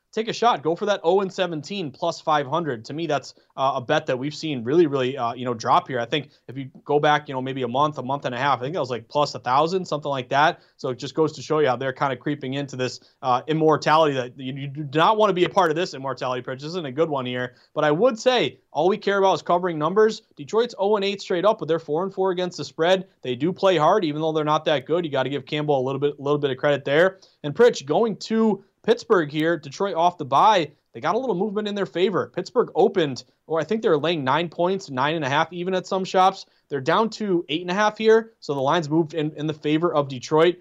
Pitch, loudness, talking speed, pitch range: 155 Hz, -23 LUFS, 285 wpm, 140-185 Hz